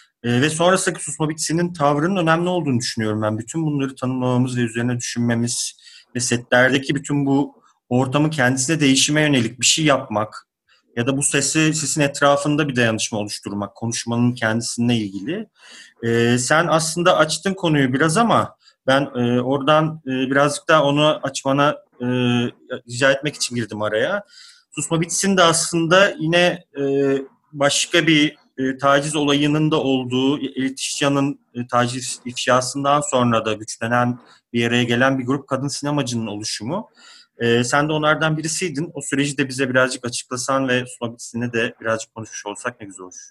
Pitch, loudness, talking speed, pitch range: 135 Hz, -19 LUFS, 150 wpm, 120-155 Hz